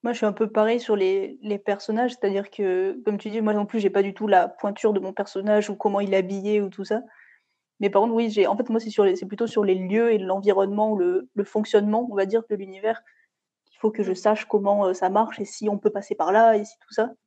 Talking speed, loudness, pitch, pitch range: 280 wpm, -23 LUFS, 210 Hz, 200-225 Hz